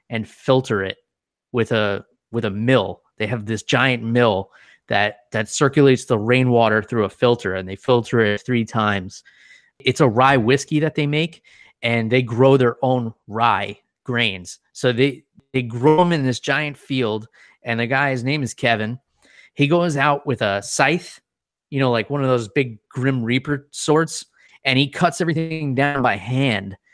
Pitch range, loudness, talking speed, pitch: 115-140 Hz, -19 LUFS, 180 wpm, 125 Hz